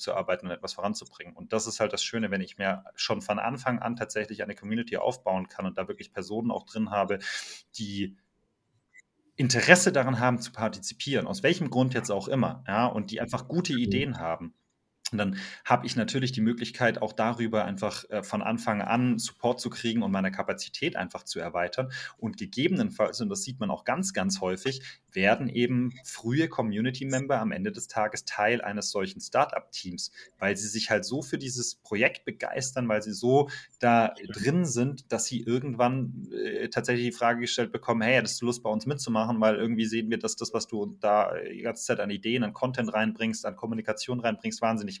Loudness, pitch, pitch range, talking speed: -29 LUFS, 115 Hz, 110-125 Hz, 195 wpm